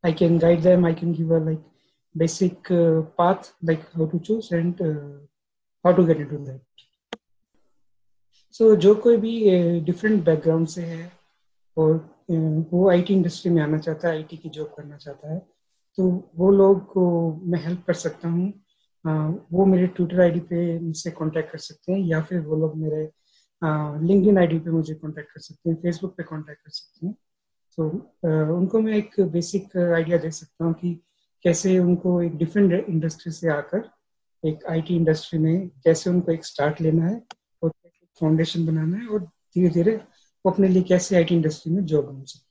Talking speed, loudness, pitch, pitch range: 140 wpm, -22 LUFS, 170 Hz, 160-180 Hz